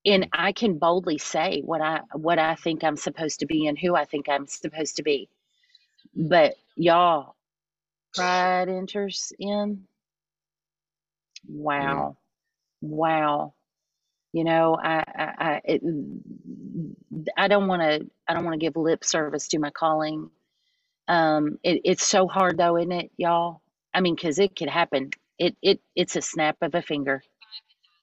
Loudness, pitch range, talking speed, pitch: -24 LUFS, 155-185 Hz, 150 wpm, 165 Hz